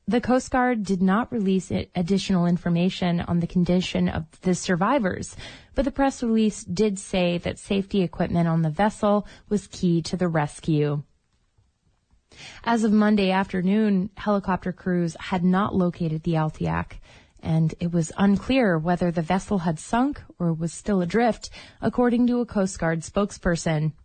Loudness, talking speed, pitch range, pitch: -24 LUFS, 150 wpm, 170-205 Hz, 185 Hz